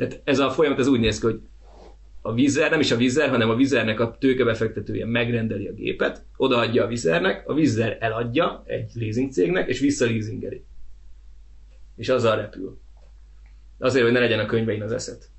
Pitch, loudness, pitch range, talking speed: 115 Hz, -22 LUFS, 95-120 Hz, 175 wpm